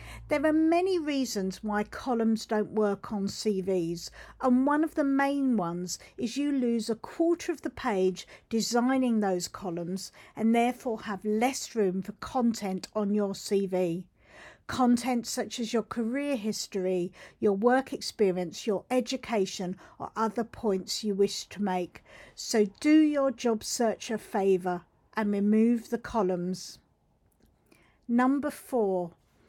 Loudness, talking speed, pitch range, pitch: -29 LUFS, 140 wpm, 195-250 Hz, 220 Hz